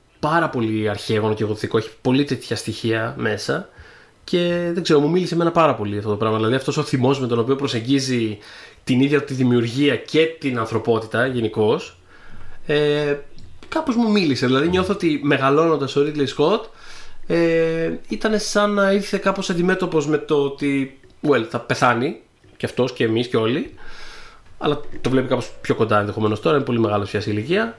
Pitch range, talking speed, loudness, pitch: 115-160 Hz, 175 wpm, -20 LUFS, 135 Hz